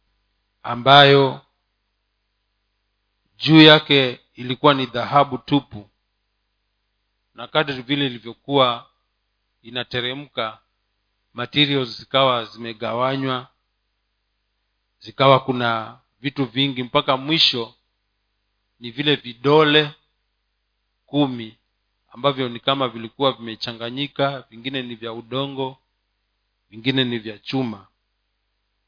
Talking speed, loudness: 80 wpm, -19 LUFS